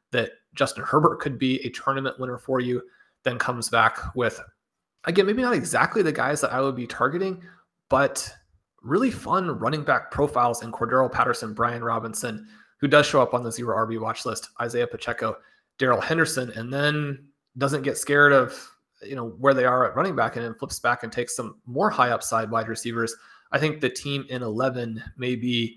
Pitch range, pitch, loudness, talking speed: 115-140 Hz, 125 Hz, -24 LUFS, 195 wpm